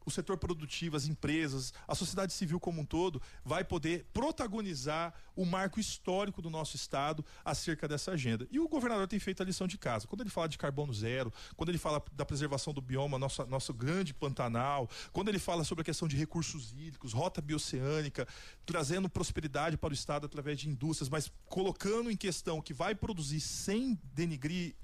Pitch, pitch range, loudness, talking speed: 160 Hz, 145-185 Hz, -37 LUFS, 185 wpm